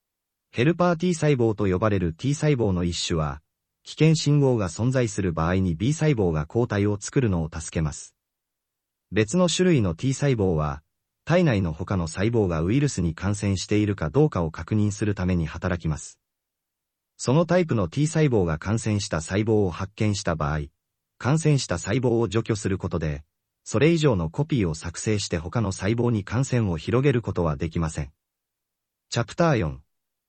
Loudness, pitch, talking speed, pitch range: -24 LUFS, 105 Hz, 325 characters per minute, 85-125 Hz